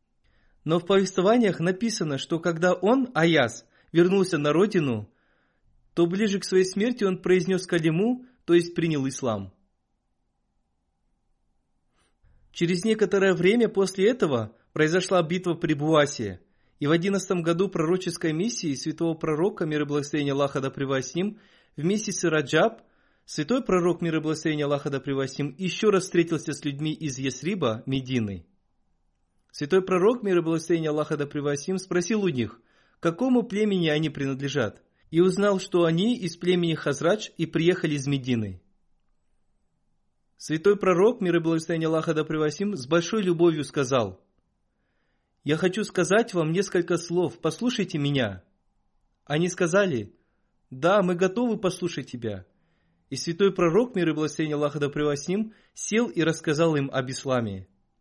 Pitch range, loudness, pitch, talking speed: 145-190 Hz, -25 LUFS, 170 Hz, 140 wpm